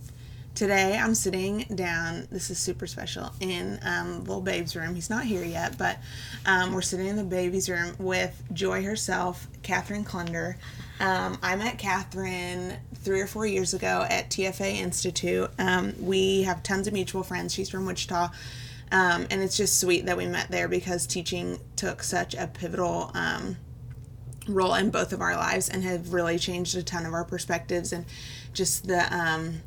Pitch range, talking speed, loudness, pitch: 165-190 Hz, 175 wpm, -28 LUFS, 180 Hz